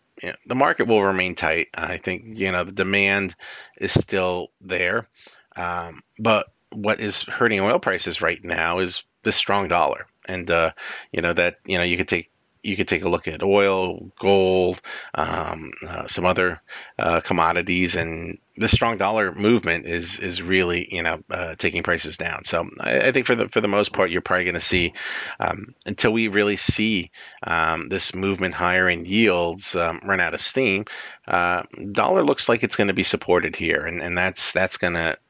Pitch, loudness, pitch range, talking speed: 90 Hz, -21 LUFS, 85-100 Hz, 190 wpm